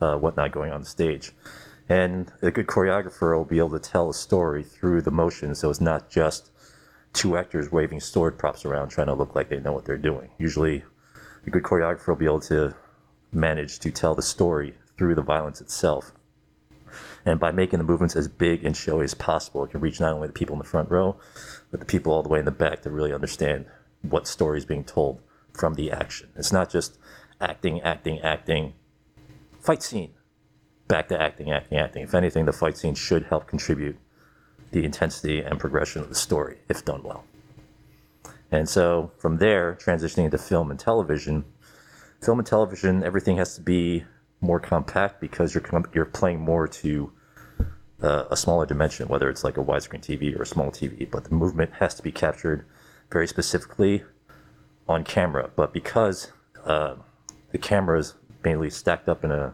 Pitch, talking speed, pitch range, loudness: 80 Hz, 195 wpm, 75-85 Hz, -25 LUFS